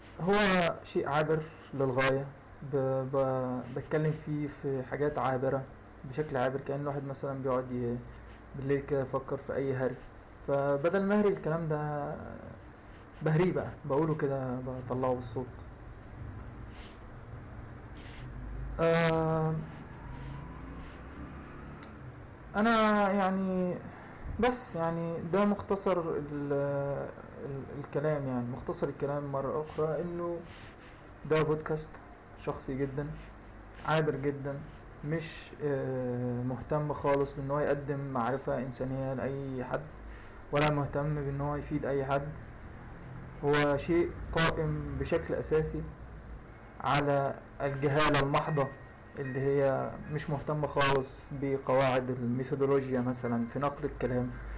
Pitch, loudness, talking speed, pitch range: 140 Hz, -32 LUFS, 95 wpm, 125-150 Hz